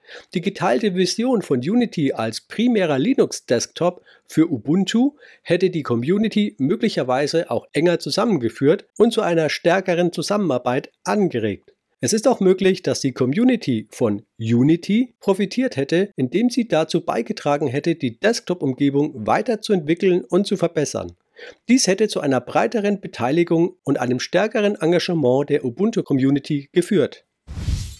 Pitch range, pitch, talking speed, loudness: 140-210 Hz, 175 Hz, 125 wpm, -20 LUFS